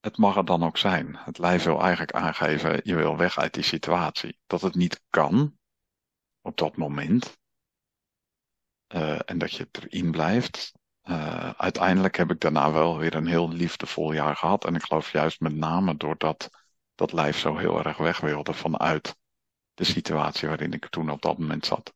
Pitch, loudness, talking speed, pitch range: 80 Hz, -26 LUFS, 180 wpm, 80-90 Hz